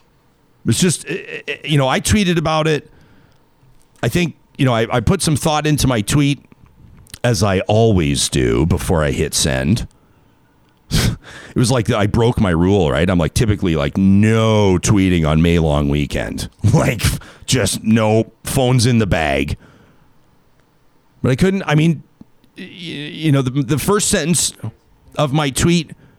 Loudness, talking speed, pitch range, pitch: -16 LUFS, 155 wpm, 105-155 Hz, 125 Hz